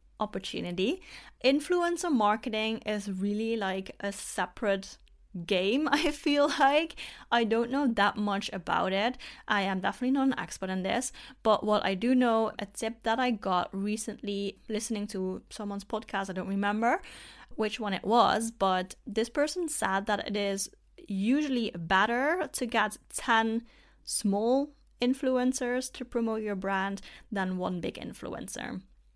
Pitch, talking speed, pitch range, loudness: 215 Hz, 145 wpm, 195-250 Hz, -30 LUFS